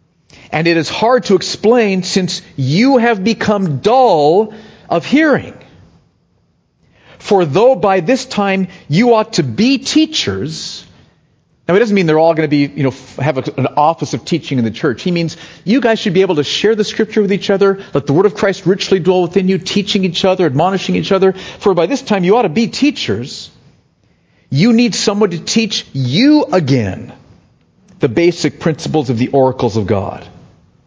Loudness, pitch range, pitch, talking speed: -13 LUFS, 155-215 Hz, 190 Hz, 190 wpm